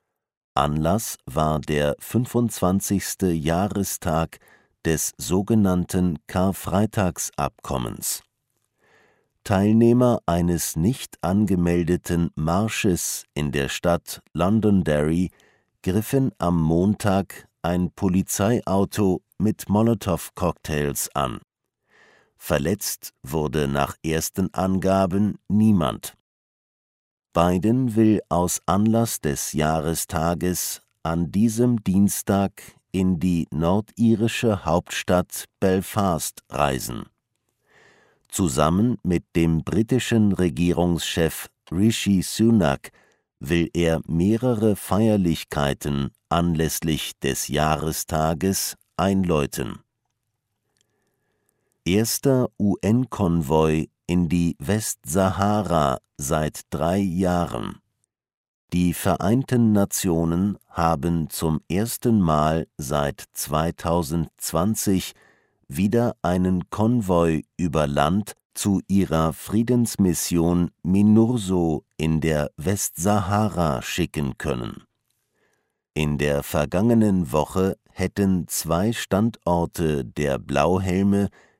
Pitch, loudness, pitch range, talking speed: 90 Hz, -22 LUFS, 80-105 Hz, 75 wpm